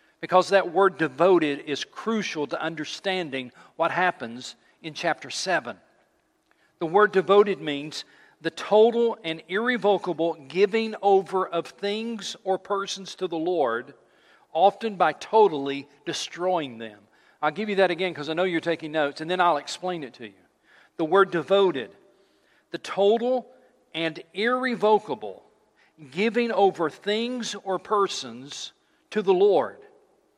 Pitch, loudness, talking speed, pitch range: 185 Hz, -24 LUFS, 135 wpm, 160-210 Hz